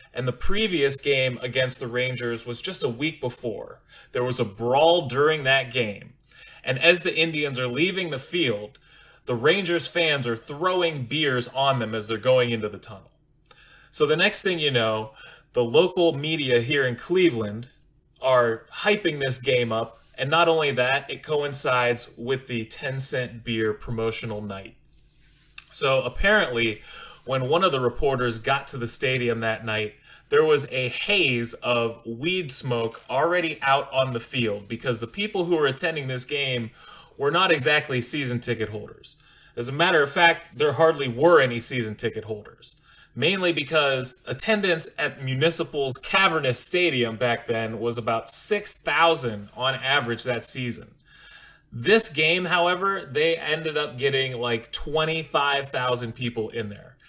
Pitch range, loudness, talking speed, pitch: 120-160 Hz, -22 LUFS, 160 wpm, 130 Hz